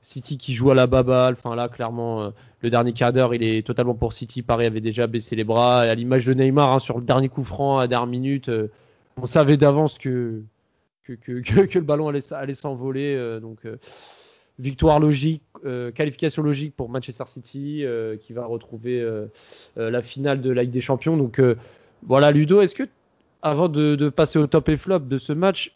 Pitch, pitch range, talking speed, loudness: 130 Hz, 120-145 Hz, 190 wpm, -21 LUFS